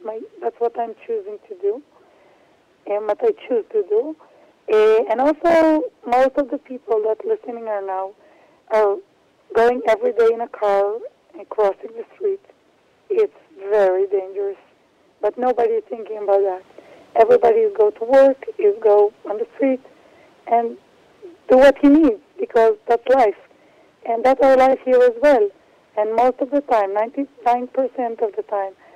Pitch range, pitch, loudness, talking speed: 215-310 Hz, 240 Hz, -18 LUFS, 165 wpm